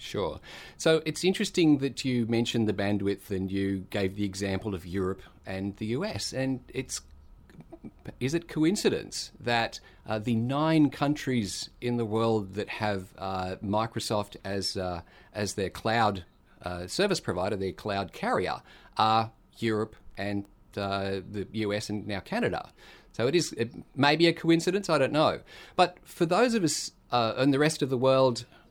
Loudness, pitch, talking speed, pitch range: -29 LUFS, 110 Hz, 160 wpm, 95-135 Hz